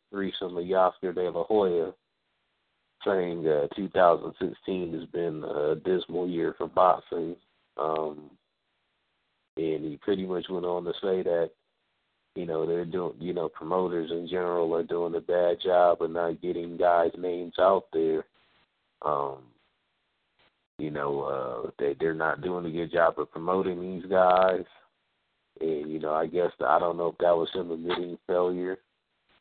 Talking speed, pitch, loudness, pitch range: 160 wpm, 85 Hz, -28 LUFS, 85-90 Hz